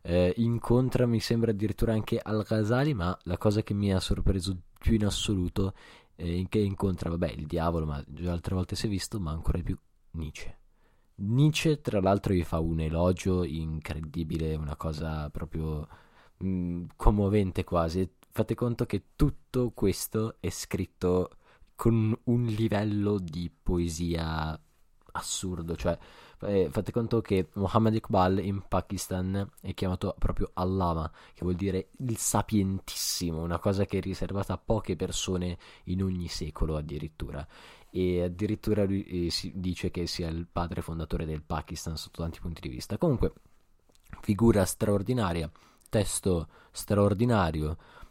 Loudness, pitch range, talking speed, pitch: -30 LUFS, 85-105 Hz, 145 wpm, 95 Hz